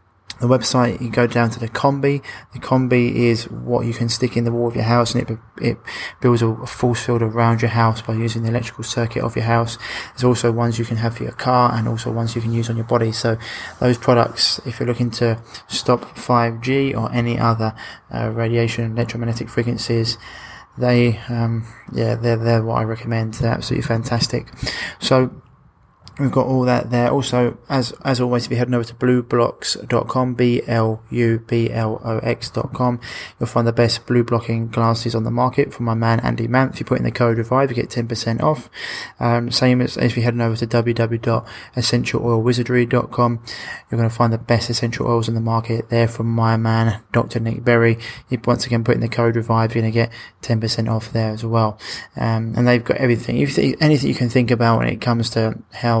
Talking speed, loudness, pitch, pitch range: 210 wpm, -19 LUFS, 115 Hz, 115-120 Hz